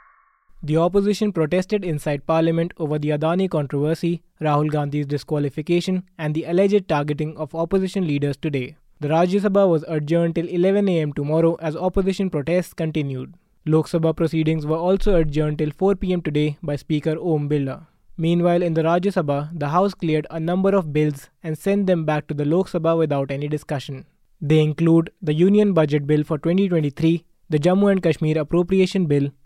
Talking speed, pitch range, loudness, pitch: 170 wpm, 150-180 Hz, -21 LUFS, 160 Hz